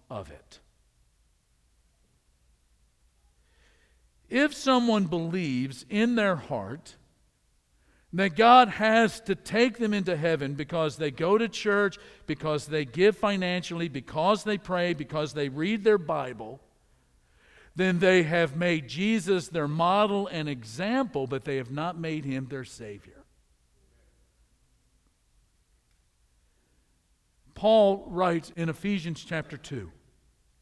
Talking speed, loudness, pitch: 110 wpm, -26 LUFS, 155 Hz